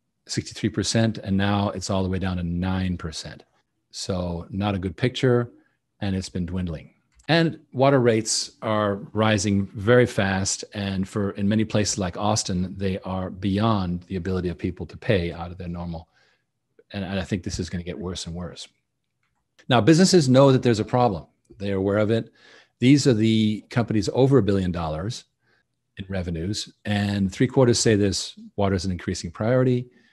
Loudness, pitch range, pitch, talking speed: -23 LUFS, 95-115 Hz, 100 Hz, 175 wpm